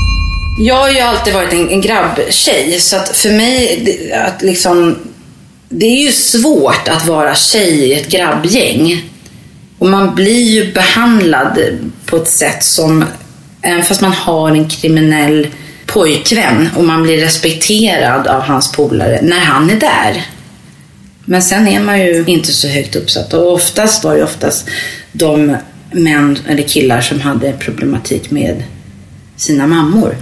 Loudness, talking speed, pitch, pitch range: -10 LUFS, 145 wpm, 165 Hz, 145-195 Hz